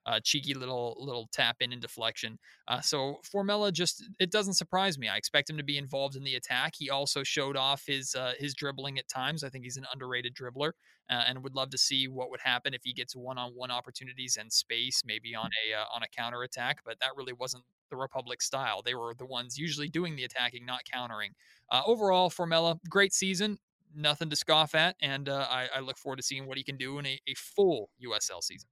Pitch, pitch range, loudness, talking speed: 135 Hz, 125-150 Hz, -31 LUFS, 225 wpm